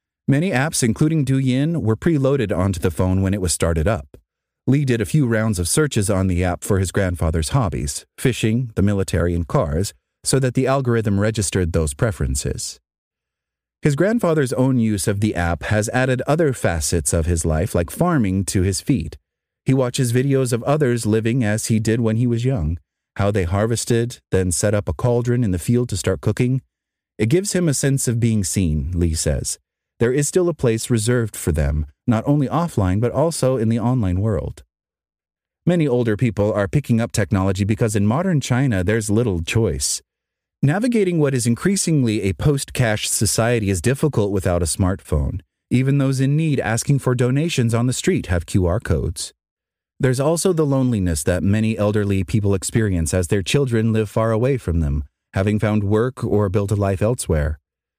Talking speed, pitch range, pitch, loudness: 180 wpm, 95-130 Hz, 110 Hz, -19 LUFS